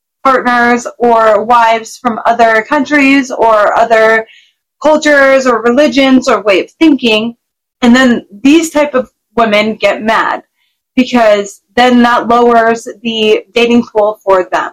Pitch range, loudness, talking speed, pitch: 220-260 Hz, -9 LUFS, 130 wpm, 240 Hz